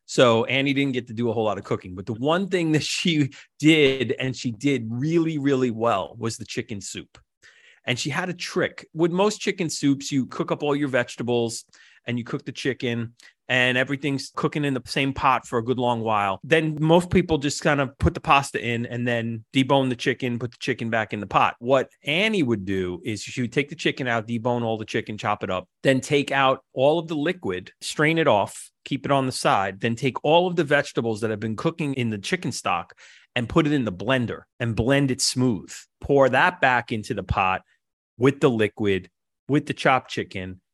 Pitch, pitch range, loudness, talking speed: 130 Hz, 115-145 Hz, -23 LUFS, 225 wpm